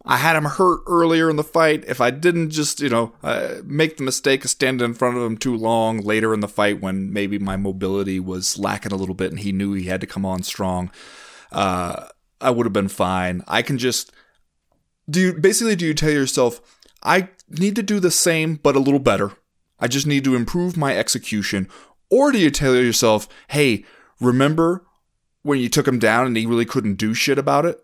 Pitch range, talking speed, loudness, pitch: 100-150 Hz, 220 wpm, -19 LUFS, 125 Hz